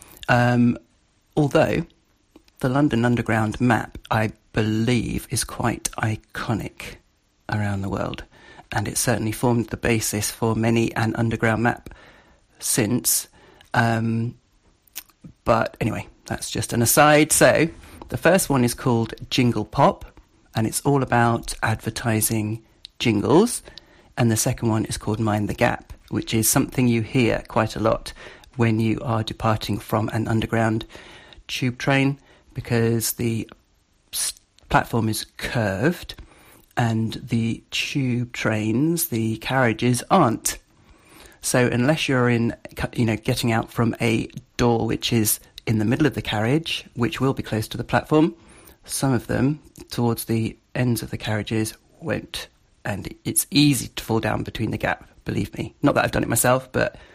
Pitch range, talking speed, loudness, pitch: 110-125 Hz, 145 wpm, -22 LUFS, 115 Hz